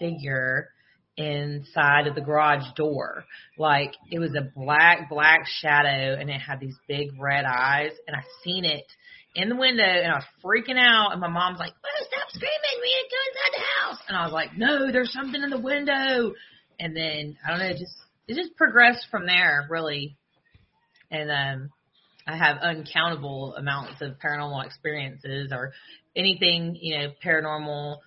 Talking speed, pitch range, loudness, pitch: 175 wpm, 145-195 Hz, -23 LUFS, 160 Hz